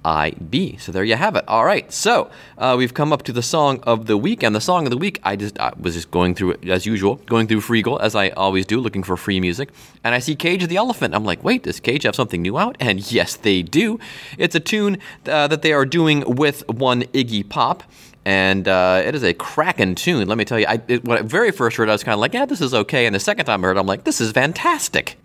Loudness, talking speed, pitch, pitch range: -18 LUFS, 275 wpm, 115 Hz, 100-150 Hz